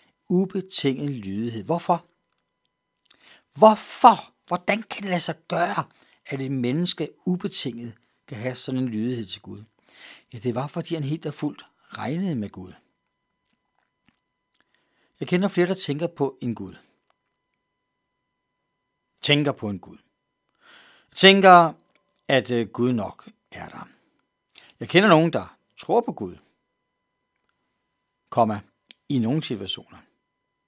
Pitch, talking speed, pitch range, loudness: 145 Hz, 120 wpm, 120-175 Hz, -22 LUFS